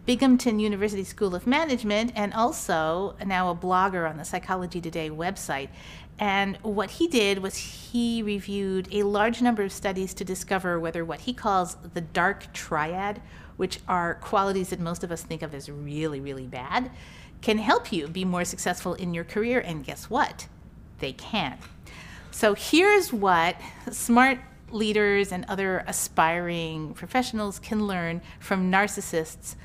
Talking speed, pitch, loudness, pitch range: 155 wpm, 195 Hz, -26 LUFS, 175-215 Hz